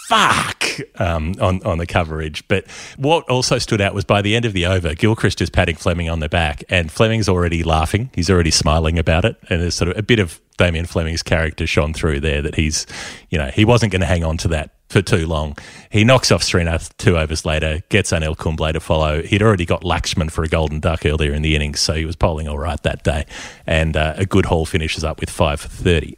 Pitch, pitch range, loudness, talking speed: 85 Hz, 80-100 Hz, -18 LUFS, 240 wpm